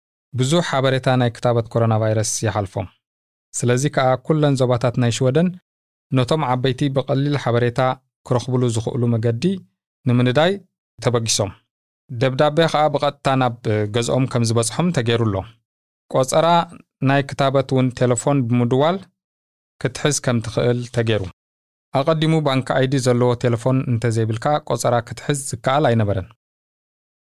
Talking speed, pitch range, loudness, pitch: 115 wpm, 115-140 Hz, -19 LUFS, 125 Hz